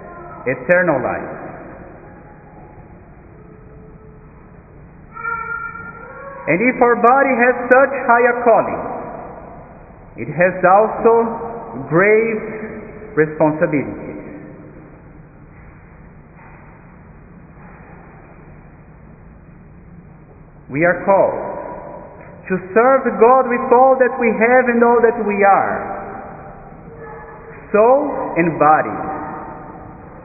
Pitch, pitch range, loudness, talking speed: 220 Hz, 165-245 Hz, -15 LUFS, 65 wpm